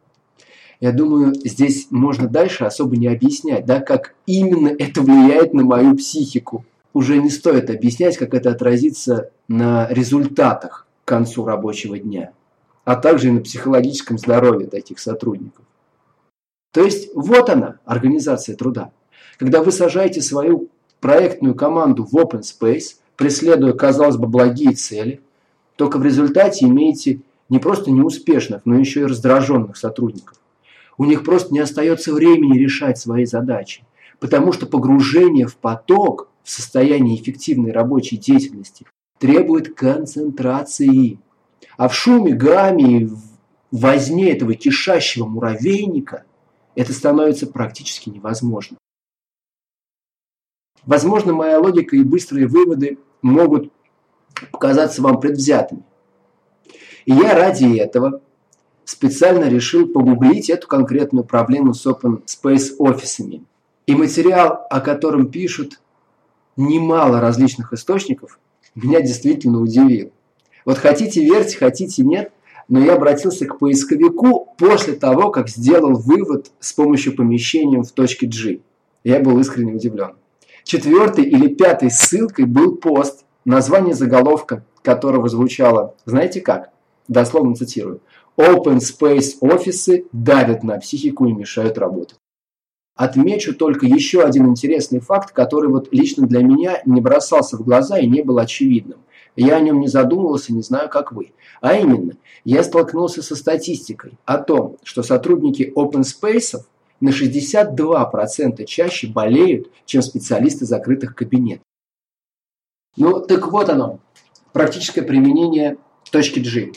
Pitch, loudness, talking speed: 145 Hz, -15 LUFS, 125 wpm